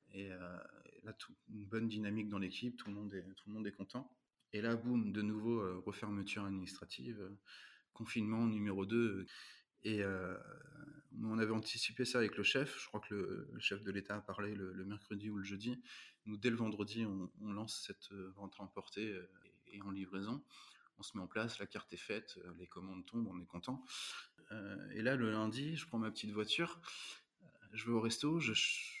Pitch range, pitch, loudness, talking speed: 100-115 Hz, 105 Hz, -42 LUFS, 215 wpm